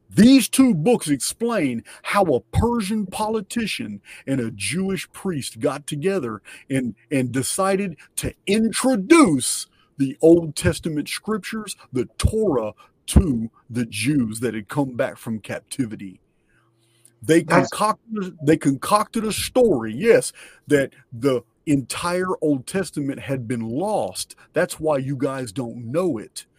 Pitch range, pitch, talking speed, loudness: 125-205 Hz, 150 Hz, 125 wpm, -22 LUFS